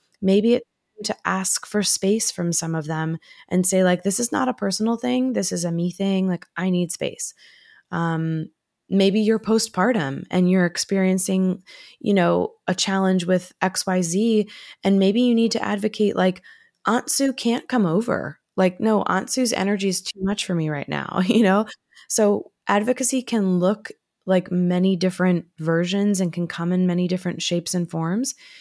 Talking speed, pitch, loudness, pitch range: 175 wpm, 190 Hz, -22 LUFS, 180-220 Hz